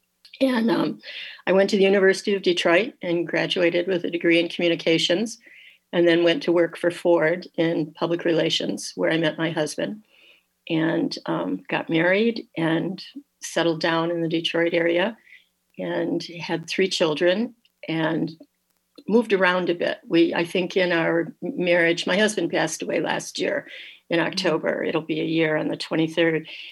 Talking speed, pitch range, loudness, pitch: 160 wpm, 165-185 Hz, -22 LUFS, 170 Hz